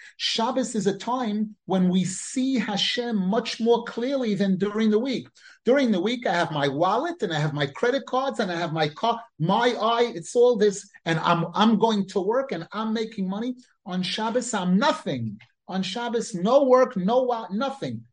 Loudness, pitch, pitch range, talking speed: -24 LUFS, 215 Hz, 185-240 Hz, 195 wpm